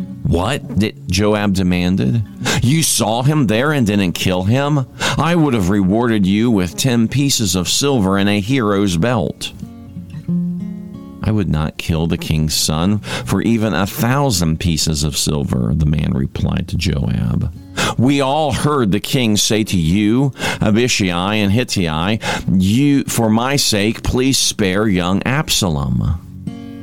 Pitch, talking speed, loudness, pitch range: 105 Hz, 145 wpm, -16 LUFS, 95-130 Hz